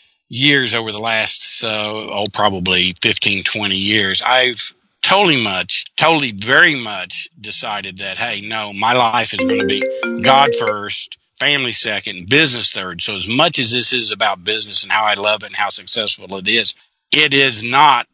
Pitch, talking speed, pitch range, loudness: 110 Hz, 180 wpm, 105-125 Hz, -14 LUFS